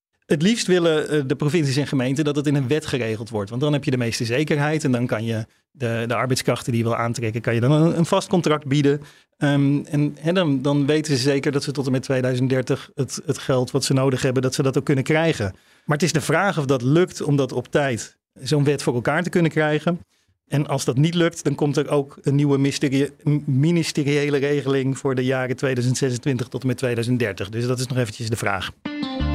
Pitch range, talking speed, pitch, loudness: 130-150 Hz, 235 wpm, 140 Hz, -21 LUFS